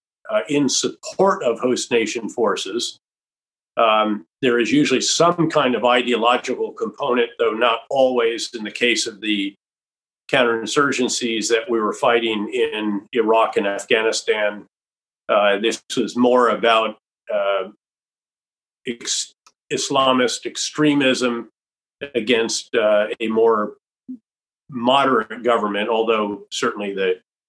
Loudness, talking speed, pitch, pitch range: -19 LUFS, 110 wpm, 120 Hz, 110-150 Hz